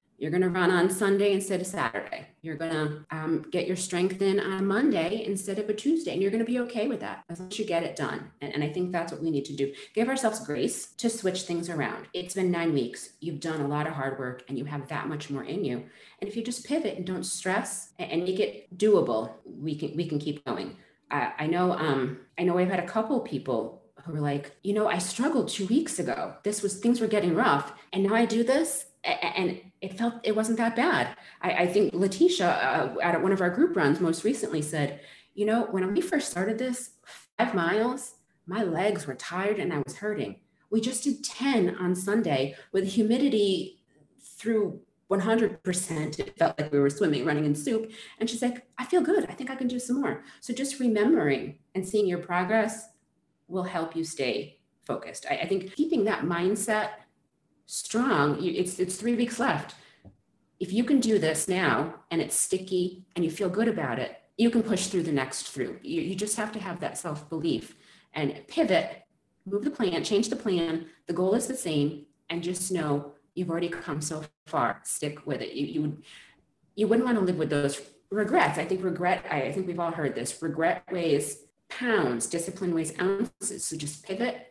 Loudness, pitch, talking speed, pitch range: -28 LUFS, 185 Hz, 215 wpm, 160-220 Hz